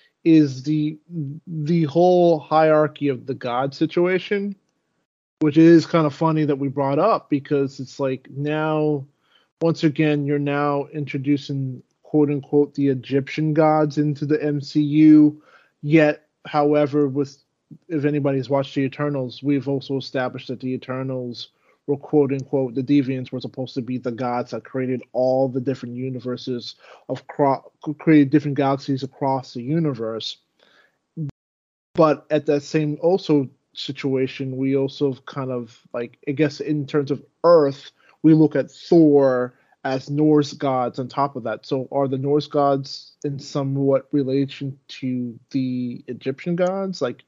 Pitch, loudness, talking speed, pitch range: 140 Hz, -21 LUFS, 145 wpm, 135-150 Hz